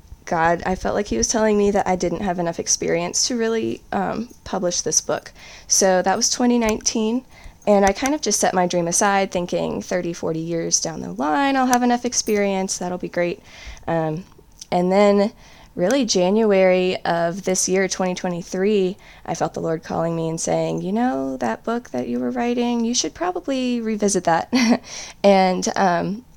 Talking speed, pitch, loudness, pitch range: 180 wpm, 190 Hz, -20 LUFS, 175-225 Hz